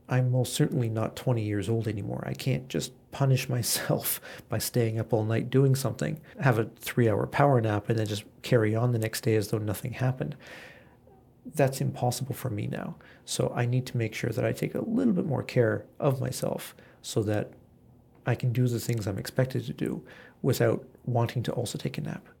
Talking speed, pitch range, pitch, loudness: 205 wpm, 110-130 Hz, 120 Hz, -29 LUFS